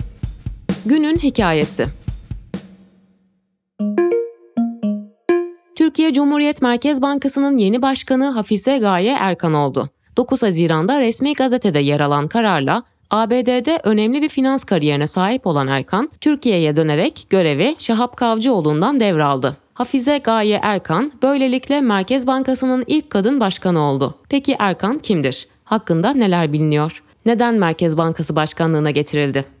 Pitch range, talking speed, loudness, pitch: 160-265 Hz, 110 wpm, -17 LUFS, 210 Hz